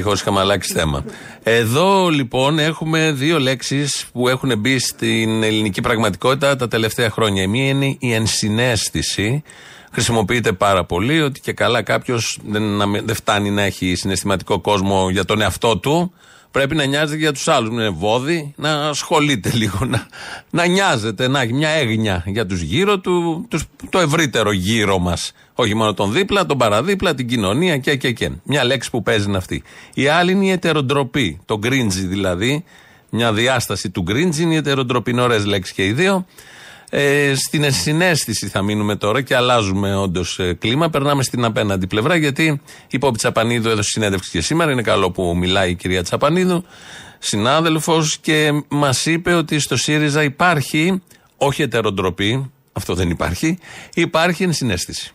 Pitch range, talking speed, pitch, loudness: 105-155 Hz, 160 wpm, 125 Hz, -17 LUFS